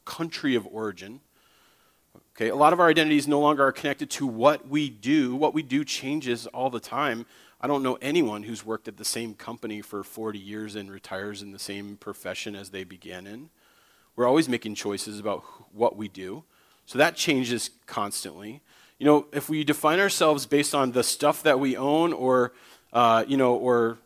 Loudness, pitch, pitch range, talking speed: -25 LUFS, 120 Hz, 105-145 Hz, 195 wpm